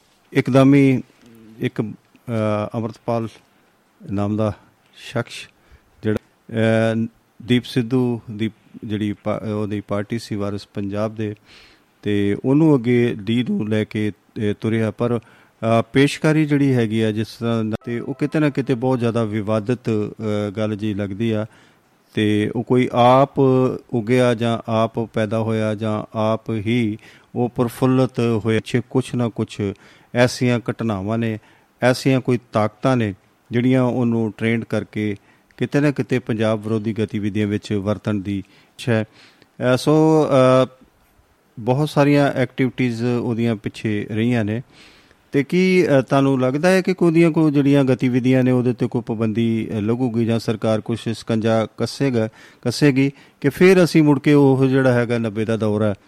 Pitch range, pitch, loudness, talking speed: 110-130 Hz, 115 Hz, -19 LUFS, 135 wpm